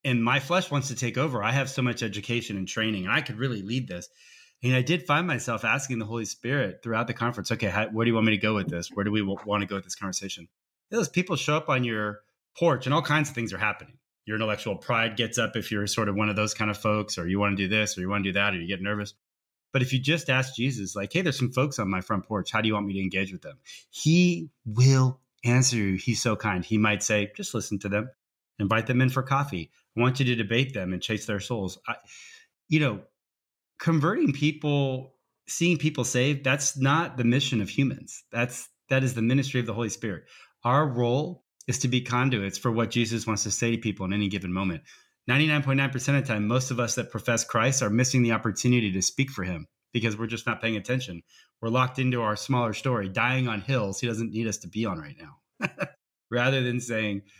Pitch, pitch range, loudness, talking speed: 120 Hz, 105-130 Hz, -26 LUFS, 245 wpm